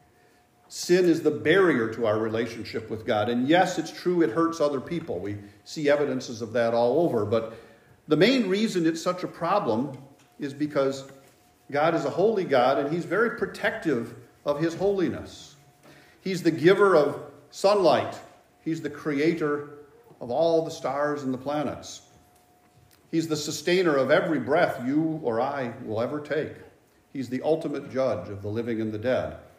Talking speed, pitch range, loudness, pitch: 170 wpm, 125-165 Hz, -25 LUFS, 145 Hz